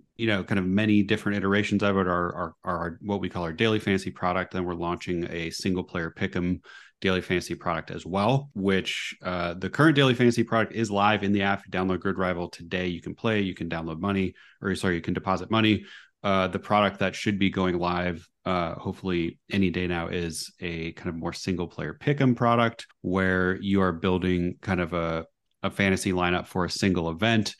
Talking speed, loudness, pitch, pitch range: 215 wpm, -26 LUFS, 95 Hz, 90-100 Hz